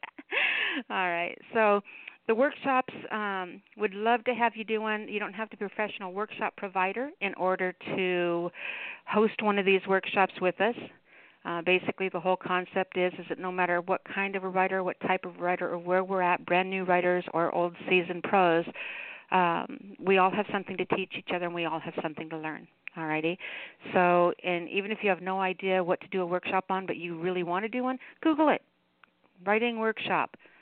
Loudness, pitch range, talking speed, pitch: -29 LUFS, 180-210 Hz, 200 wpm, 185 Hz